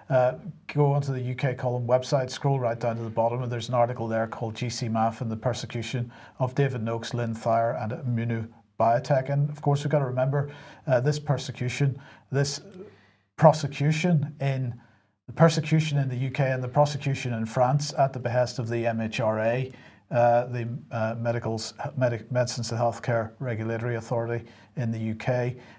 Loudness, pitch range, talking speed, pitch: -27 LUFS, 115-140 Hz, 170 wpm, 125 Hz